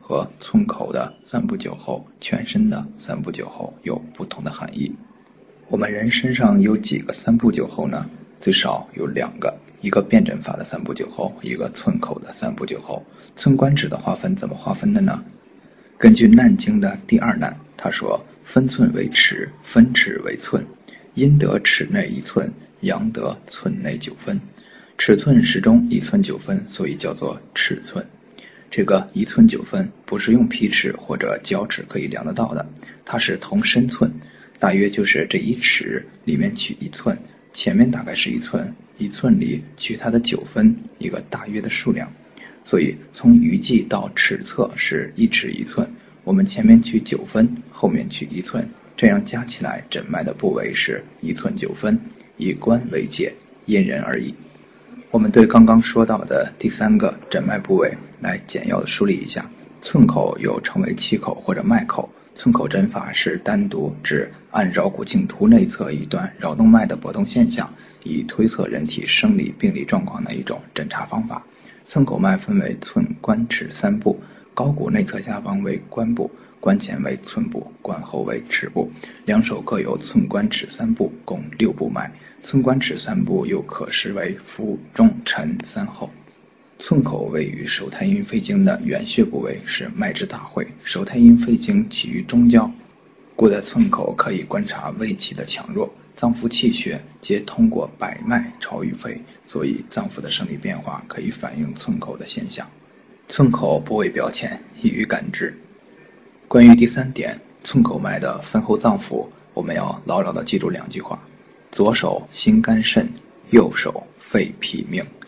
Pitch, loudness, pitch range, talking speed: 210 Hz, -19 LUFS, 195-225 Hz, 245 characters per minute